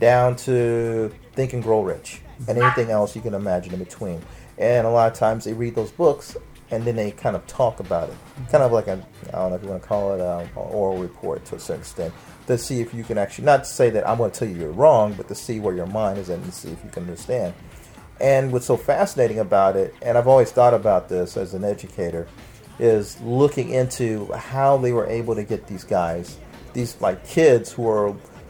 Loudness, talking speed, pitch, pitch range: -21 LUFS, 240 wpm, 115 Hz, 100-120 Hz